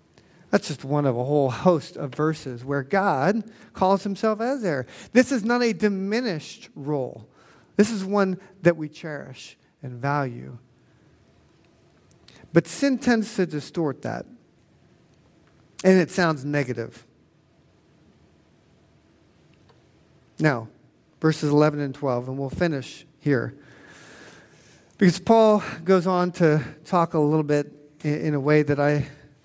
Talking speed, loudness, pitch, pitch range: 125 wpm, -23 LUFS, 155 Hz, 145-185 Hz